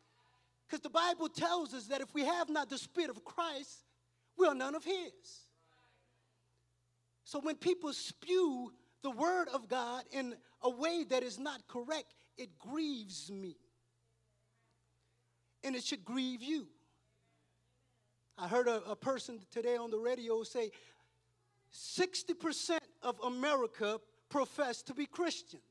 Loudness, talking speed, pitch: -38 LUFS, 140 wpm, 250 Hz